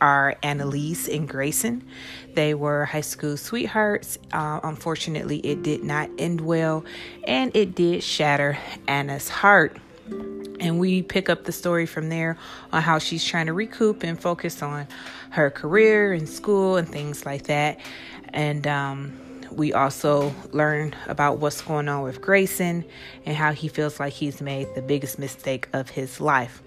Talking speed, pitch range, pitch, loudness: 160 wpm, 145-170 Hz, 150 Hz, -24 LUFS